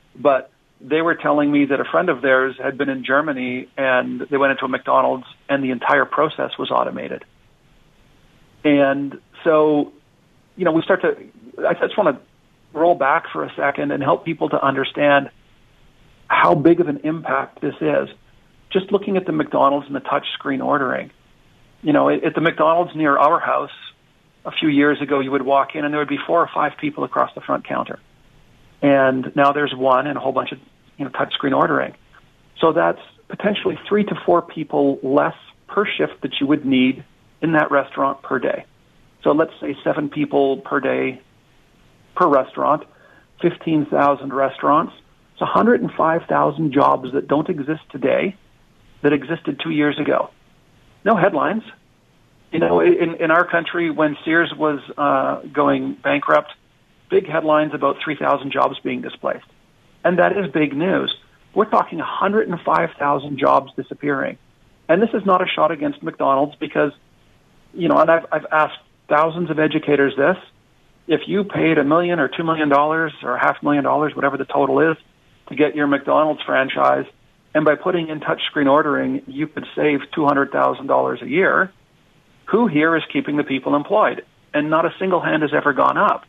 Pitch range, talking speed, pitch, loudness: 140-165 Hz, 175 wpm, 150 Hz, -19 LUFS